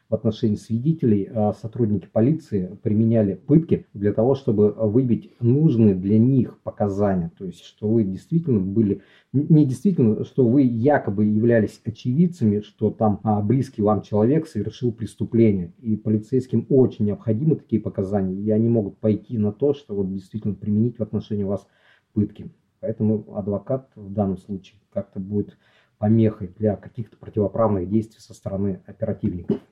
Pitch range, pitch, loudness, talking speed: 105-115 Hz, 110 Hz, -22 LUFS, 140 wpm